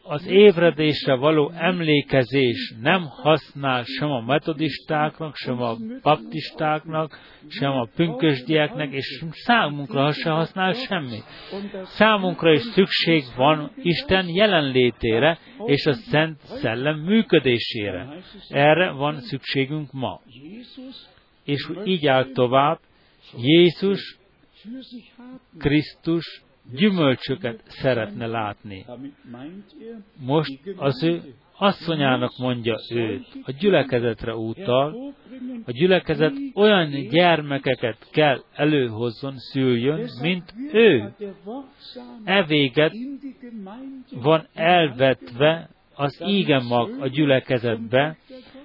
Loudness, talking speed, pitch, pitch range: -21 LUFS, 85 wpm, 155 Hz, 135-185 Hz